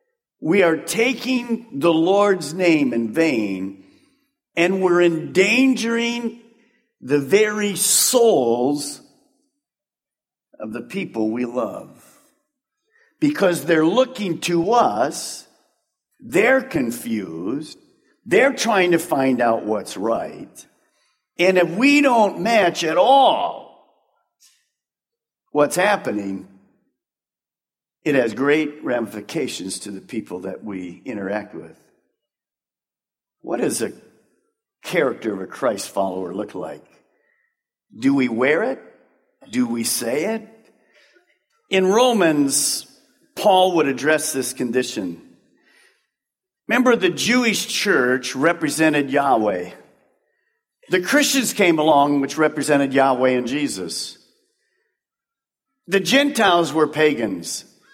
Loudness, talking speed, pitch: -19 LUFS, 100 wpm, 195 Hz